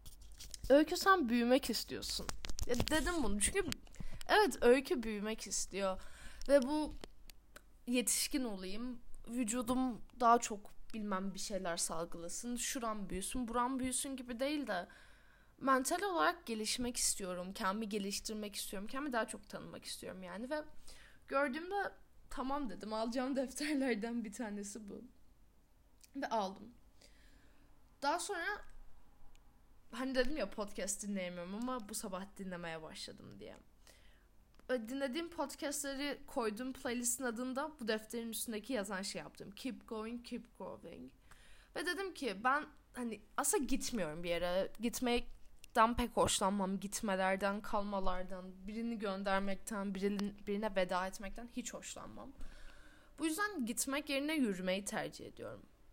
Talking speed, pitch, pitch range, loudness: 120 wpm, 235 Hz, 200-265 Hz, -38 LUFS